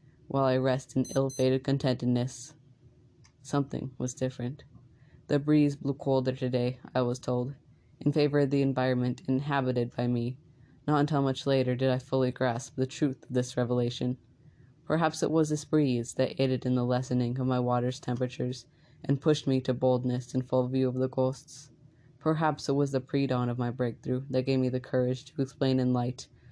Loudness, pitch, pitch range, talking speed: -29 LUFS, 130 Hz, 125-140 Hz, 185 wpm